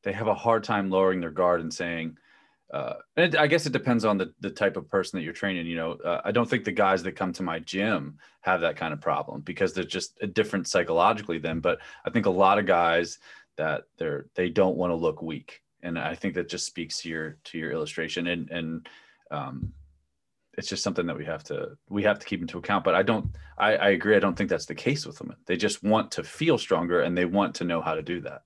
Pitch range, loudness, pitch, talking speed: 80-105 Hz, -27 LUFS, 90 Hz, 255 wpm